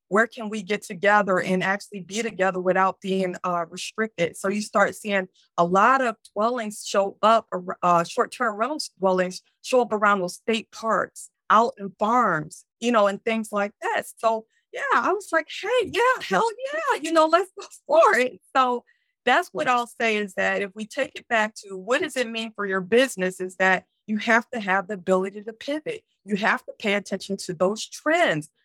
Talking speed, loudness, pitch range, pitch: 205 wpm, -23 LUFS, 195-245 Hz, 215 Hz